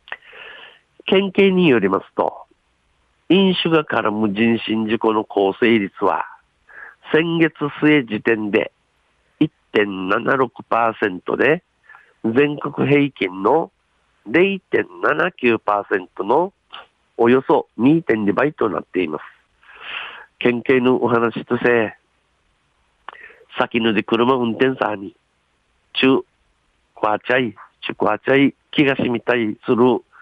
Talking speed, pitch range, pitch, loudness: 160 characters per minute, 110-145 Hz, 120 Hz, -18 LUFS